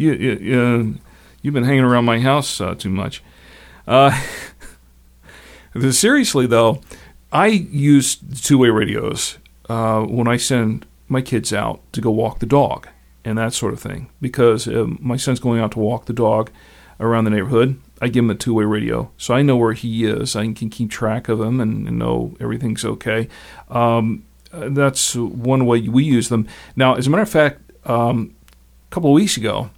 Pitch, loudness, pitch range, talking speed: 115 Hz, -18 LUFS, 110-130 Hz, 185 wpm